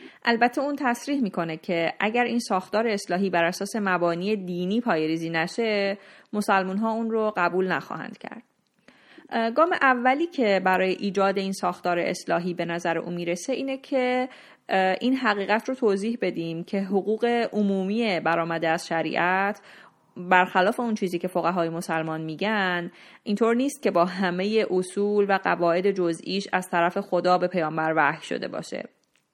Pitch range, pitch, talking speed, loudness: 175-225 Hz, 195 Hz, 145 wpm, -25 LUFS